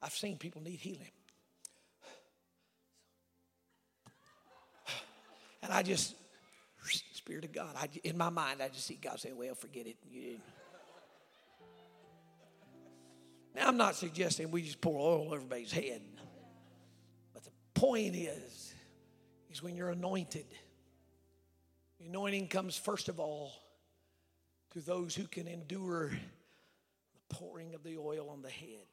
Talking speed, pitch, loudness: 130 wpm, 145 Hz, -39 LUFS